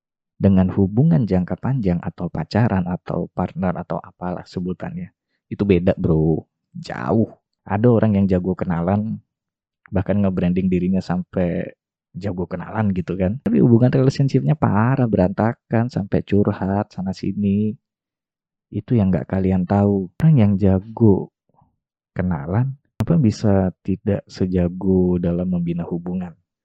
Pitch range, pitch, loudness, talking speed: 90-110 Hz, 95 Hz, -20 LUFS, 120 wpm